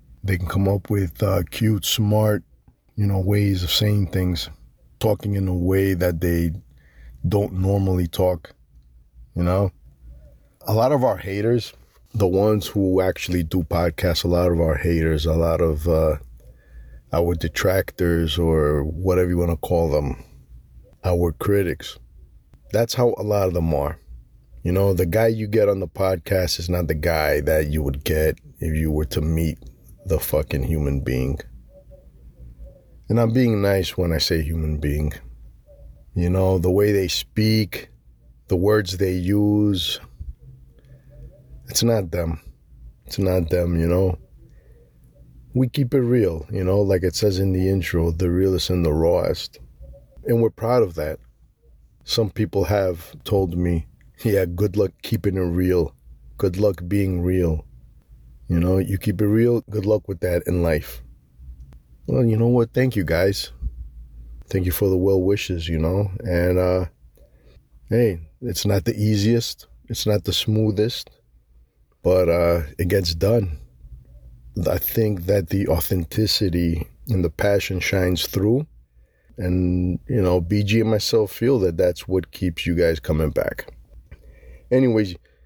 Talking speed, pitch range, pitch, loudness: 155 wpm, 75-100 Hz, 90 Hz, -21 LUFS